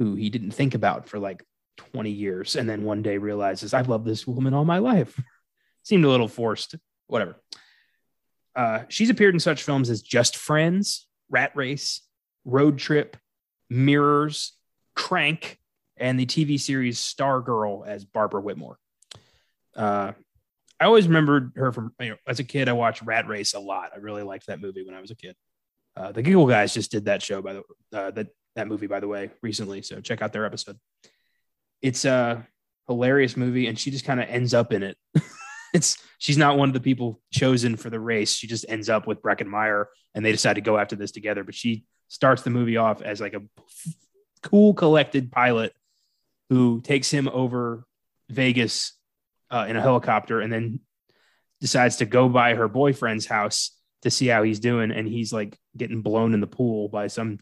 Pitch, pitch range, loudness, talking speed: 120 Hz, 110-140 Hz, -23 LUFS, 195 wpm